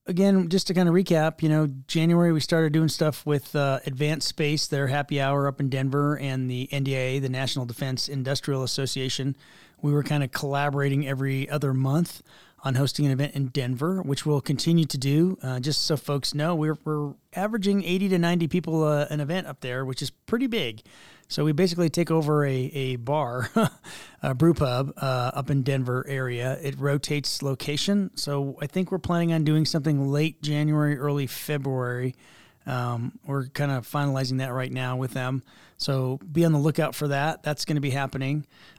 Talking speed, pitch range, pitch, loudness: 190 wpm, 135-160 Hz, 145 Hz, -26 LUFS